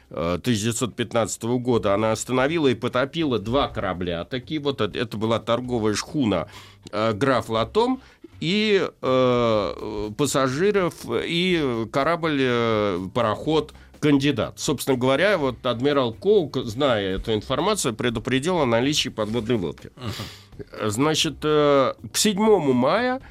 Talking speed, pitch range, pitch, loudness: 105 wpm, 110-150 Hz, 125 Hz, -22 LUFS